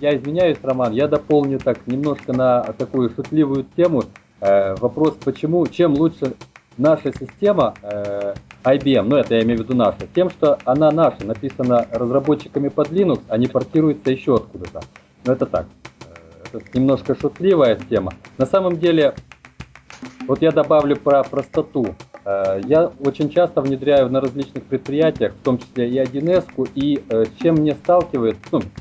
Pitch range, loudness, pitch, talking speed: 125-155 Hz, -18 LUFS, 140 Hz, 160 wpm